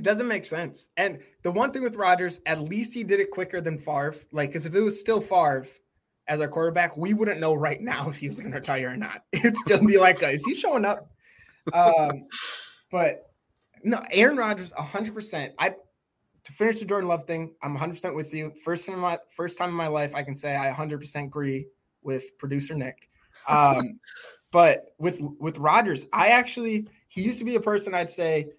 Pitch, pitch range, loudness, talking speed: 175 Hz, 150-210 Hz, -25 LUFS, 210 wpm